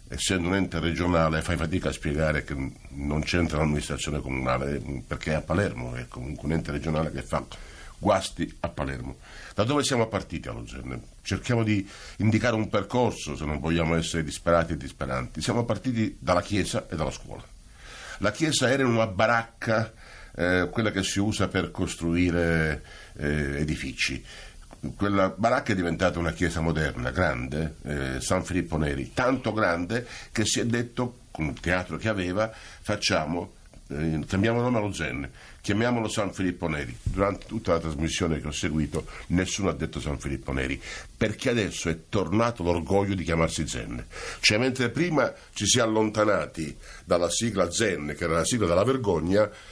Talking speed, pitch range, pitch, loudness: 165 wpm, 75-105 Hz, 85 Hz, -27 LUFS